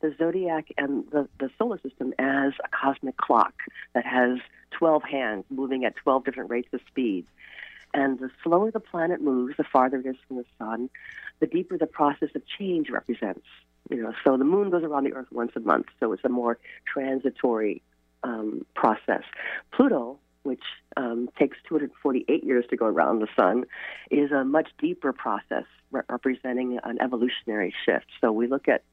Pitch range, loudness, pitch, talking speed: 125-155 Hz, -27 LUFS, 135 Hz, 180 wpm